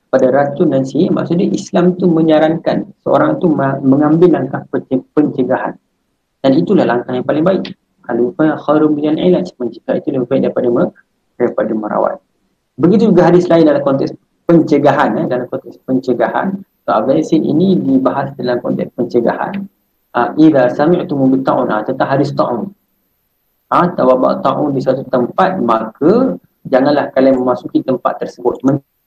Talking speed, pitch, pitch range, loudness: 150 wpm, 145 Hz, 130-170 Hz, -13 LUFS